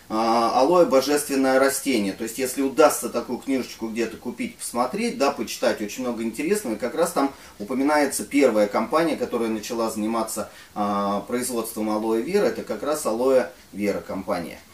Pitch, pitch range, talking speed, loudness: 115 Hz, 110-130 Hz, 145 wpm, -23 LUFS